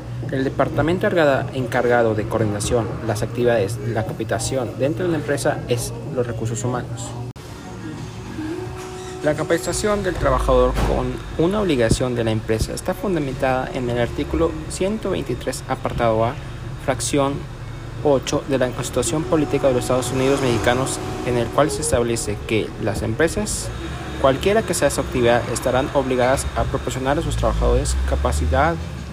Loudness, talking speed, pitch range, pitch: -21 LUFS, 140 wpm, 115-140 Hz, 125 Hz